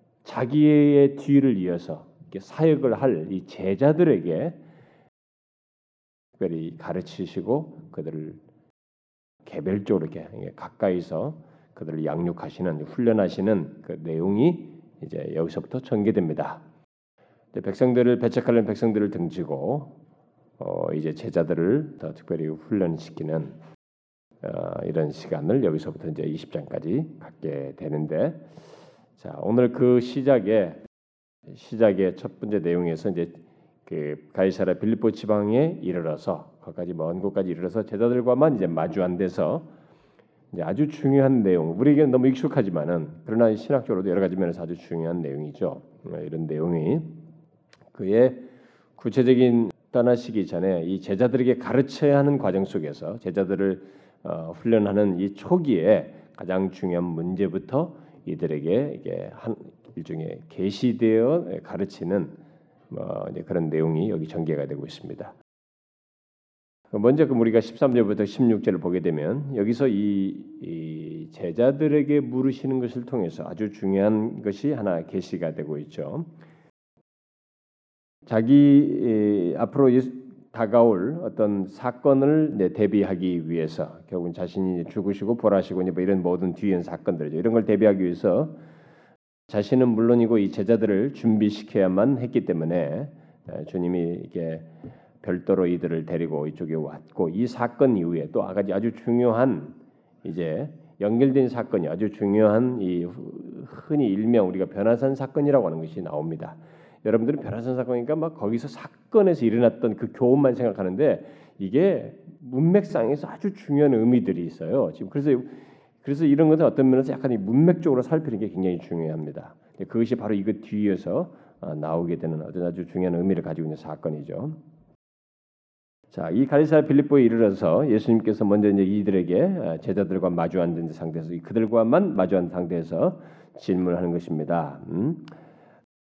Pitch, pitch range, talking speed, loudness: 105 Hz, 85-125 Hz, 310 characters per minute, -24 LUFS